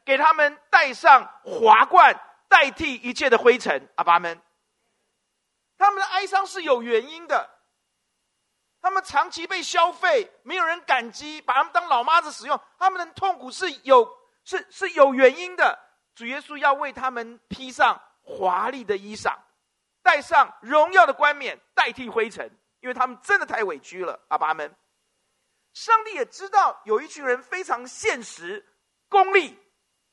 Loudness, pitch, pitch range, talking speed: -21 LUFS, 320 Hz, 255-385 Hz, 225 characters per minute